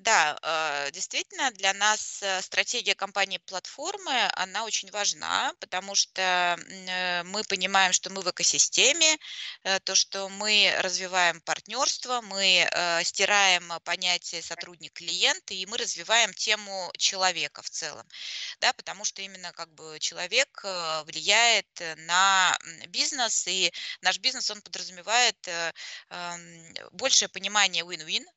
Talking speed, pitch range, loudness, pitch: 110 wpm, 175-210 Hz, -25 LUFS, 190 Hz